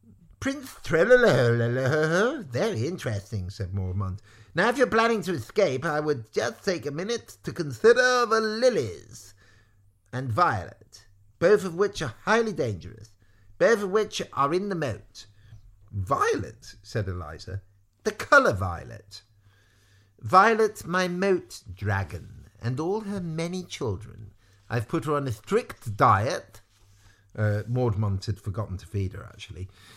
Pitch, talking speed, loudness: 110 Hz, 135 wpm, -25 LUFS